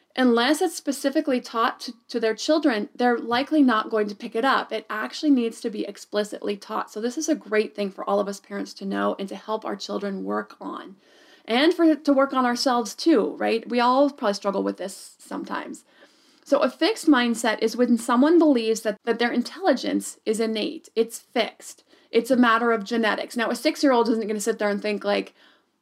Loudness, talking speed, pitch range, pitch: -23 LUFS, 215 wpm, 215-285 Hz, 235 Hz